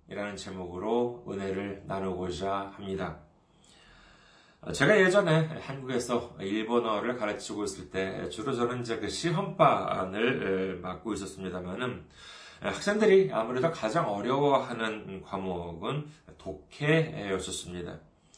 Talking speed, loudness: 260 characters per minute, -30 LUFS